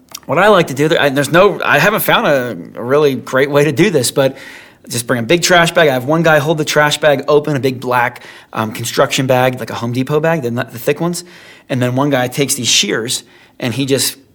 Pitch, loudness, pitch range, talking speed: 135 Hz, -13 LUFS, 125-150 Hz, 245 wpm